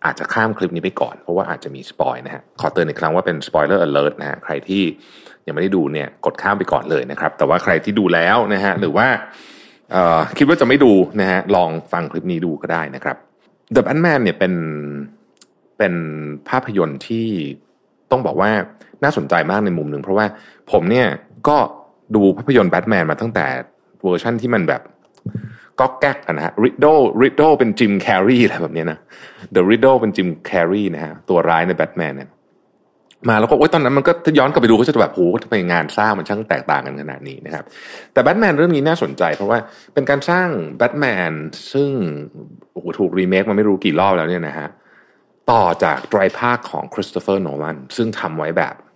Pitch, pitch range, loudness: 100 Hz, 85-115 Hz, -17 LUFS